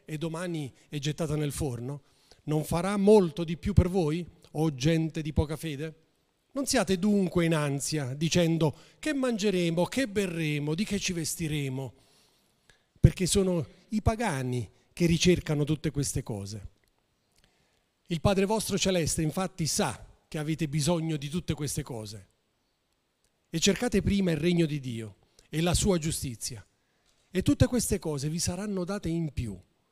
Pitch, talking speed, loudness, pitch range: 160 Hz, 150 wpm, -29 LUFS, 140-180 Hz